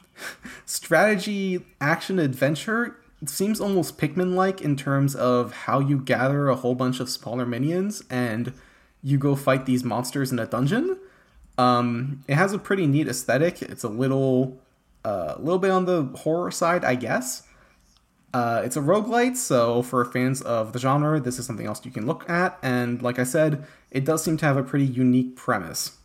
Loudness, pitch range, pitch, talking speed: -24 LUFS, 125-170 Hz, 135 Hz, 180 wpm